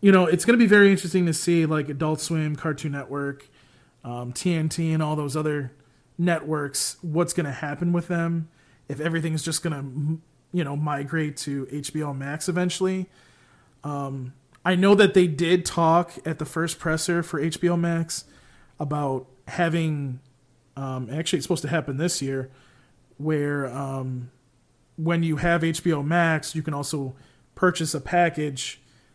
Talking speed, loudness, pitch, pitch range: 160 wpm, -24 LUFS, 155 Hz, 140-170 Hz